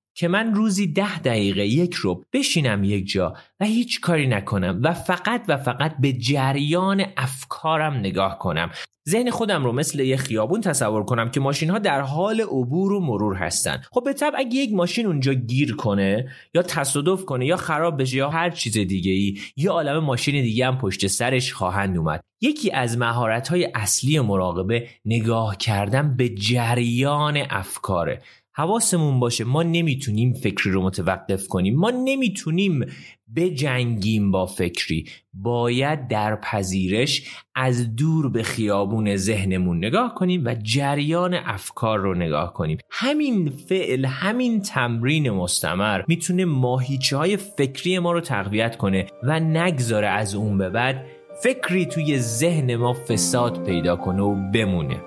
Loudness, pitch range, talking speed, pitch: -22 LUFS, 105-170 Hz, 150 wpm, 130 Hz